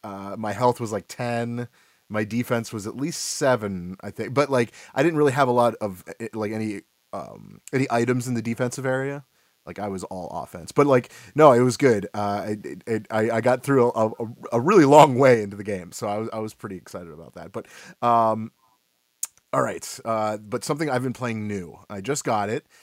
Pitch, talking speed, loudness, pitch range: 115 Hz, 220 wpm, -23 LUFS, 105-125 Hz